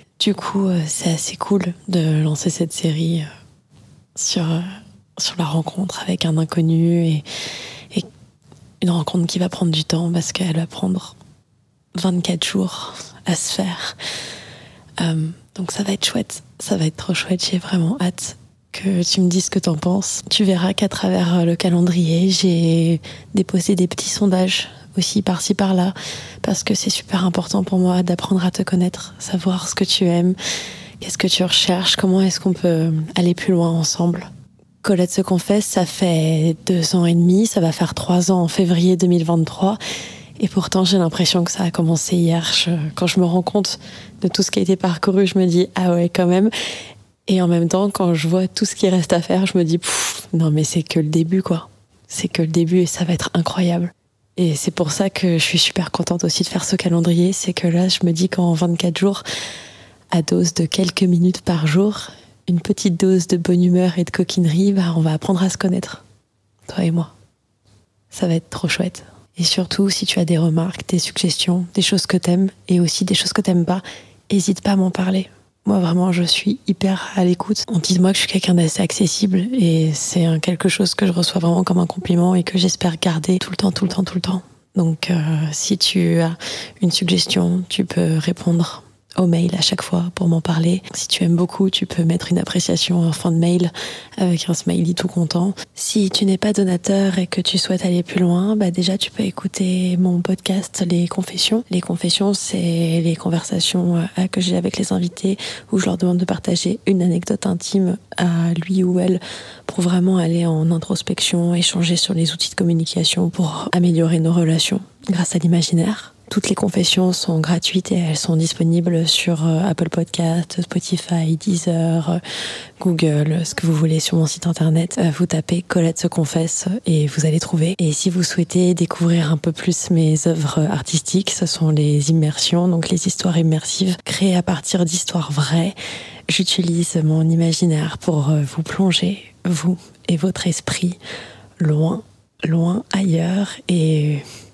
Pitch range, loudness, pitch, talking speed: 165-190 Hz, -18 LUFS, 180 Hz, 195 wpm